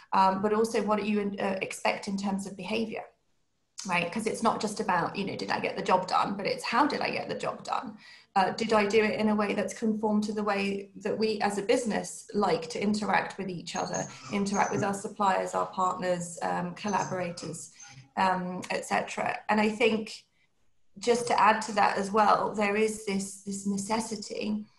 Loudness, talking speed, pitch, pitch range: -29 LUFS, 205 wpm, 205 Hz, 190-220 Hz